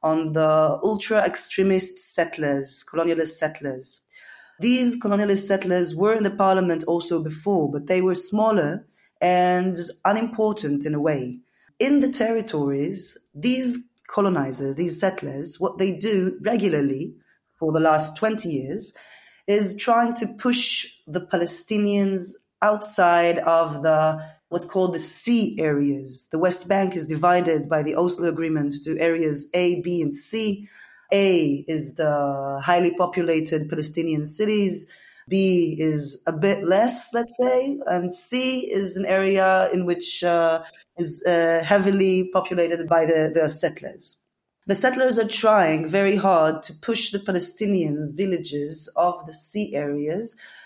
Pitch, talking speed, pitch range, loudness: 175 Hz, 135 wpm, 160-200 Hz, -21 LUFS